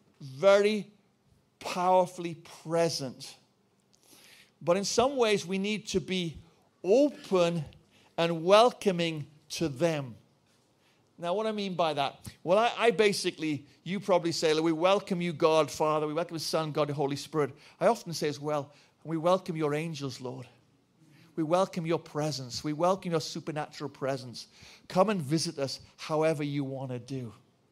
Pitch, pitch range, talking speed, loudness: 160 Hz, 145-185 Hz, 150 wpm, -29 LUFS